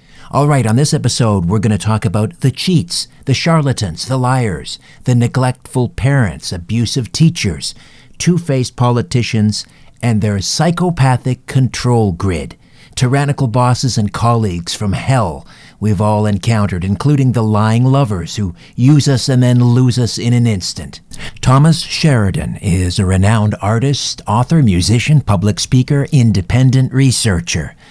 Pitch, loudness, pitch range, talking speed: 120 Hz, -14 LUFS, 105-135 Hz, 135 wpm